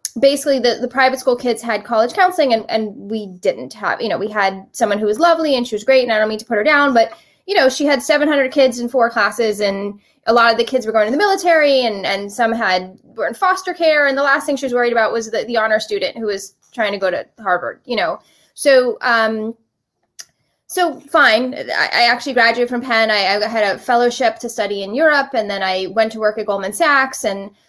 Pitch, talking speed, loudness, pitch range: 230 Hz, 245 wpm, -16 LUFS, 215-270 Hz